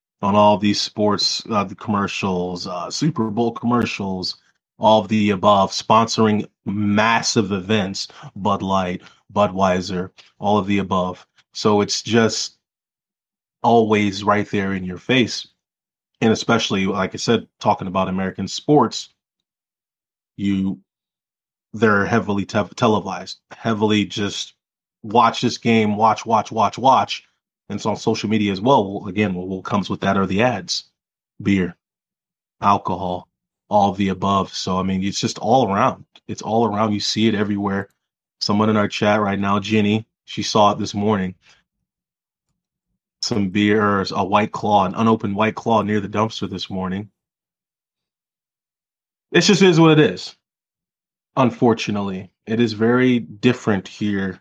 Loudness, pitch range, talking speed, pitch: -19 LUFS, 95-110 Hz, 140 wpm, 105 Hz